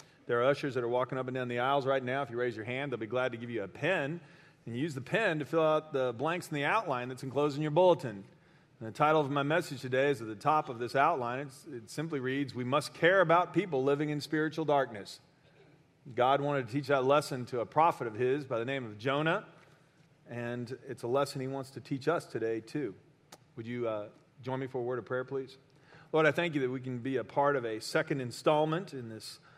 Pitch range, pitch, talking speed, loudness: 125-155 Hz, 140 Hz, 255 wpm, -32 LUFS